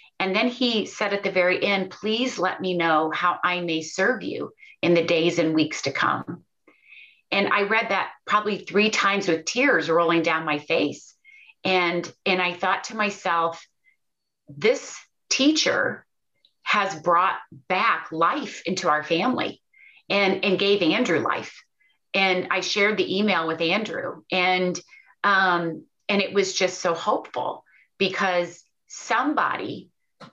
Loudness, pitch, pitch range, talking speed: -23 LUFS, 185 Hz, 170-205 Hz, 145 wpm